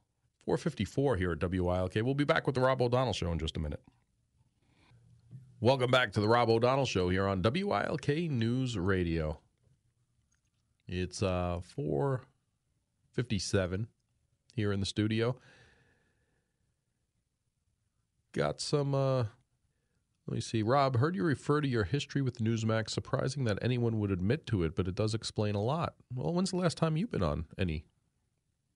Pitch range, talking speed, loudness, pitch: 100-130 Hz, 155 wpm, -32 LUFS, 115 Hz